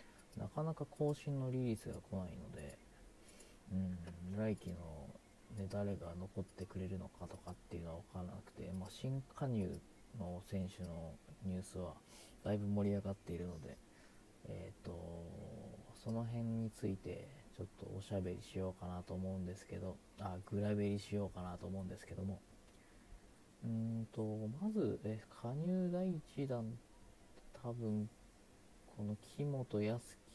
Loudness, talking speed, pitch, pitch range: -45 LUFS, 285 characters per minute, 100 Hz, 90-115 Hz